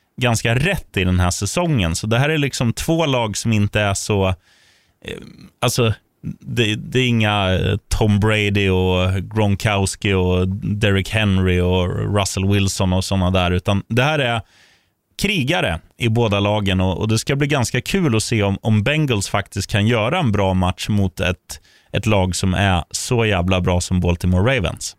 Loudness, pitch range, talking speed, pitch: -18 LUFS, 95-115 Hz, 175 wpm, 100 Hz